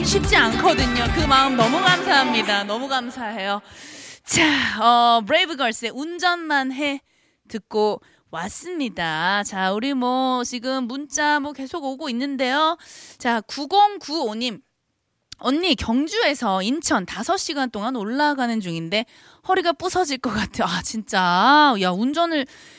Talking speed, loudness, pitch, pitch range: 250 characters per minute, -20 LUFS, 265 Hz, 225-305 Hz